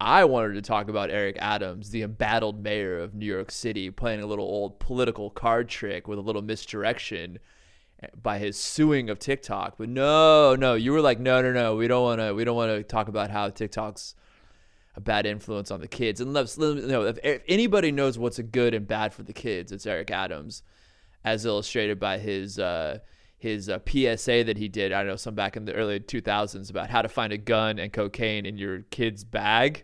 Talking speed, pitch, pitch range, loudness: 215 wpm, 110 Hz, 100-120 Hz, -26 LUFS